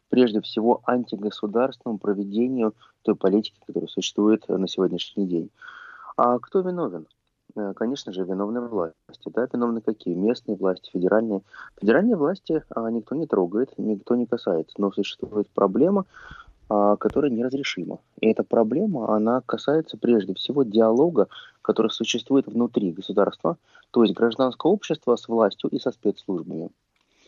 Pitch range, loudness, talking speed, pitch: 100-120 Hz, -24 LUFS, 130 wpm, 110 Hz